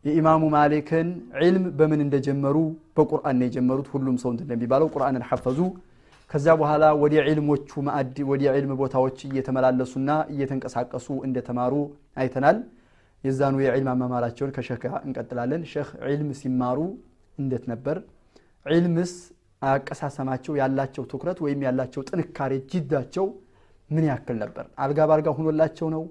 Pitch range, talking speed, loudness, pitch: 130-155 Hz, 115 wpm, -24 LUFS, 140 Hz